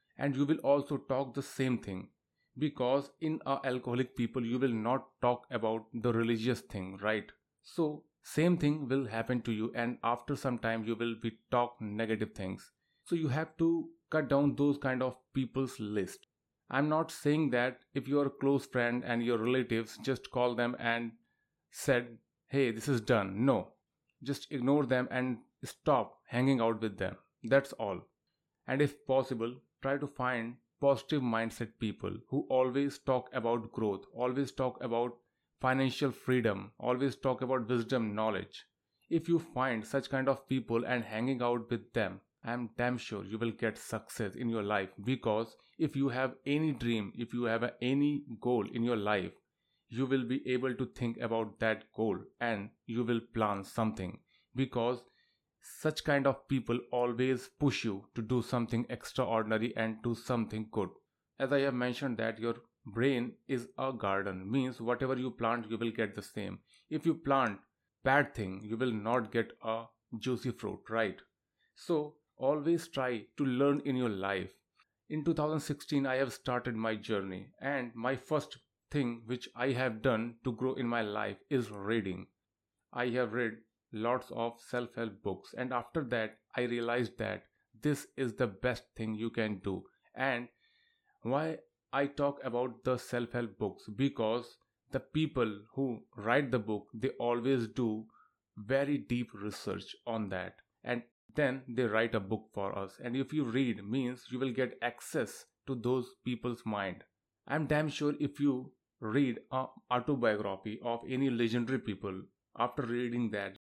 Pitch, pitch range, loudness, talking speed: 125 Hz, 115-135 Hz, -34 LUFS, 165 wpm